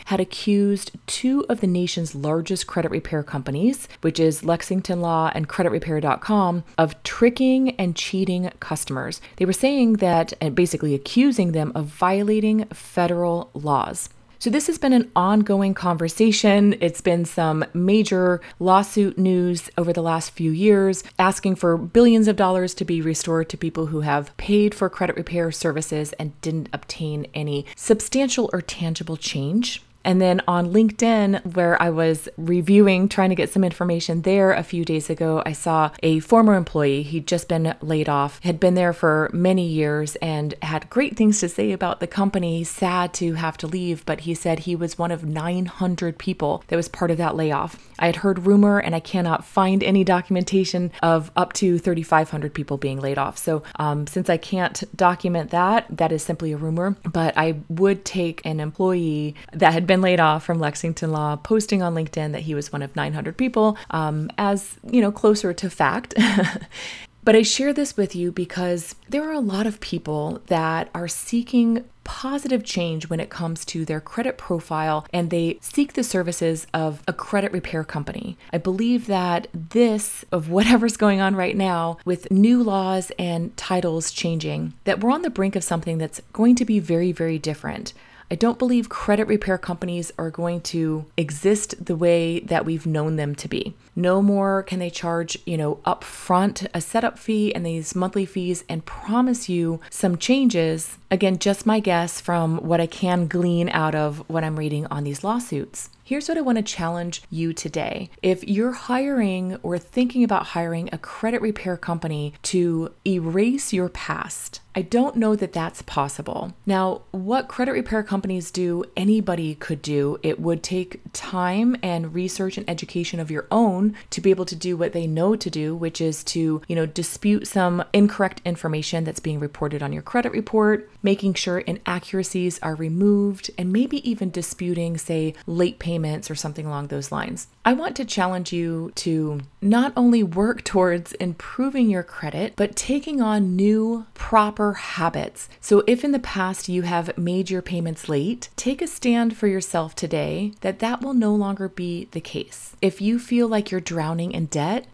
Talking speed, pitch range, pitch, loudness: 180 wpm, 165-205 Hz, 180 Hz, -22 LUFS